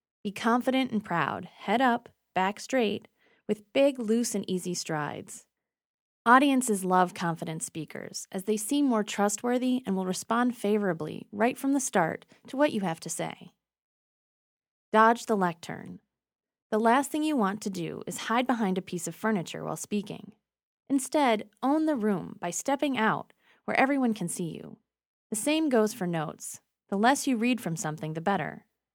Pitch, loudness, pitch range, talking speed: 215 Hz, -28 LUFS, 185-245 Hz, 170 wpm